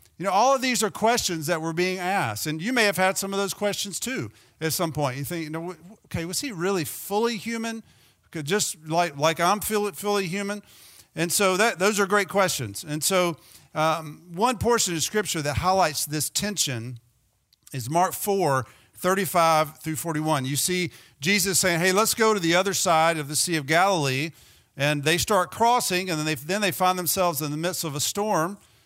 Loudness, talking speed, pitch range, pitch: -24 LUFS, 200 wpm, 155-200 Hz, 175 Hz